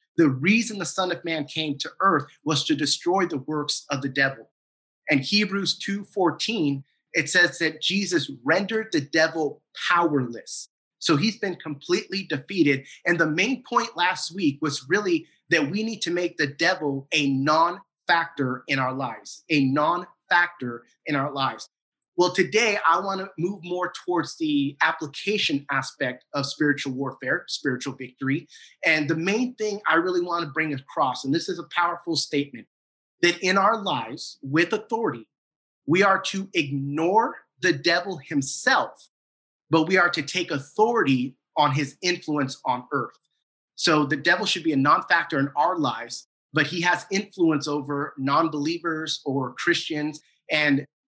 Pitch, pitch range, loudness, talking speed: 160 Hz, 145-180 Hz, -24 LUFS, 155 wpm